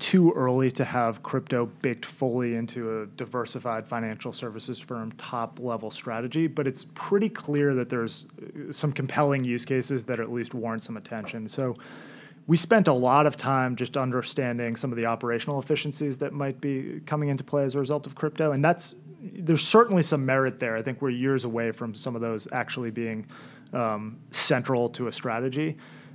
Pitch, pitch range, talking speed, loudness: 130 Hz, 120-145 Hz, 185 wpm, -27 LUFS